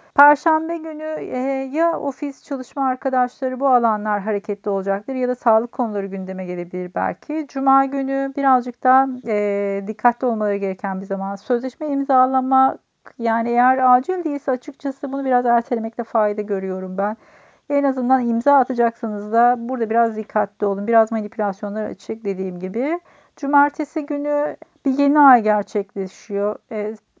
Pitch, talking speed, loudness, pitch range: 245 Hz, 135 wpm, -20 LUFS, 210-275 Hz